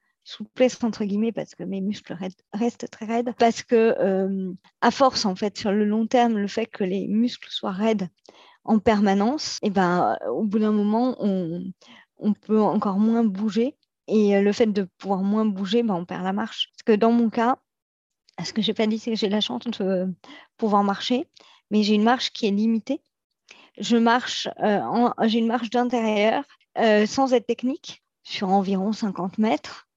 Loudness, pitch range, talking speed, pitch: -23 LUFS, 200-235 Hz, 200 wpm, 220 Hz